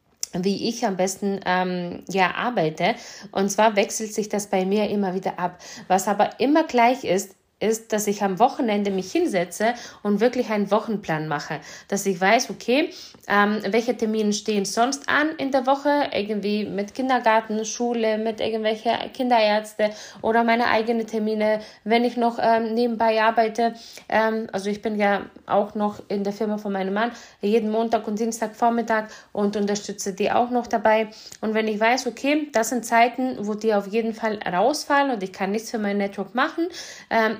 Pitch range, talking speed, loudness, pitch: 200-235 Hz, 180 wpm, -23 LUFS, 220 Hz